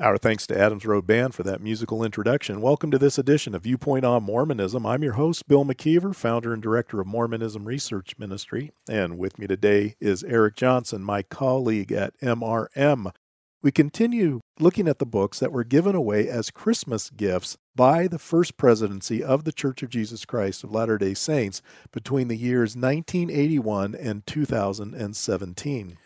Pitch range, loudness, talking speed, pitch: 105-140 Hz, -24 LUFS, 170 wpm, 115 Hz